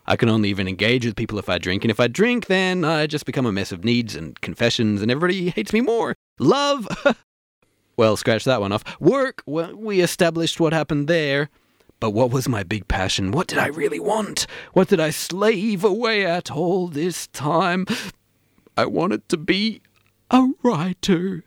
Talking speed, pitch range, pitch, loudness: 190 wpm, 115-185 Hz, 160 Hz, -21 LUFS